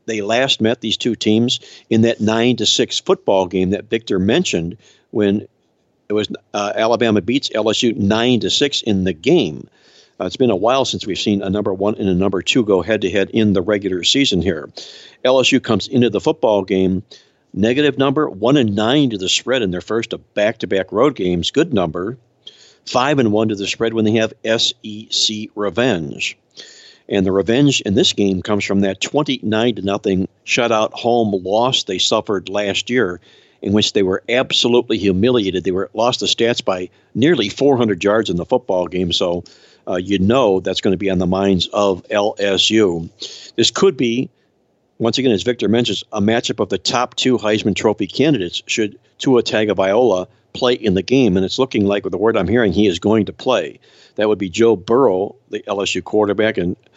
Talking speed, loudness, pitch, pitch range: 195 wpm, -17 LUFS, 105 Hz, 95-115 Hz